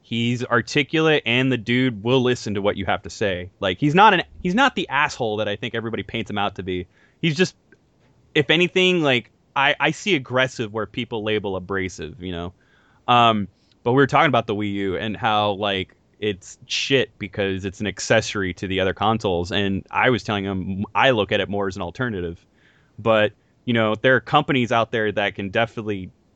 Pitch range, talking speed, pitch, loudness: 100-125 Hz, 205 wpm, 110 Hz, -21 LUFS